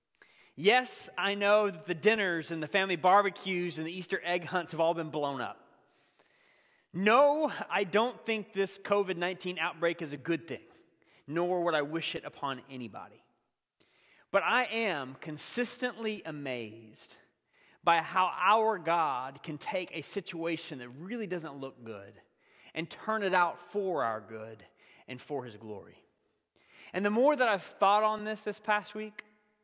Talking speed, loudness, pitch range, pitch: 160 wpm, -31 LUFS, 155-210 Hz, 180 Hz